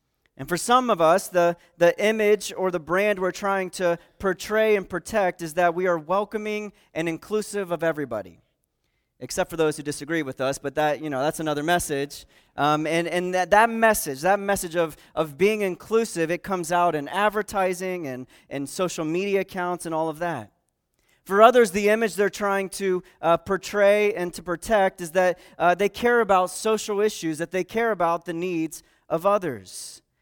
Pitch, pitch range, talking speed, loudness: 180 Hz, 165-205 Hz, 185 wpm, -23 LUFS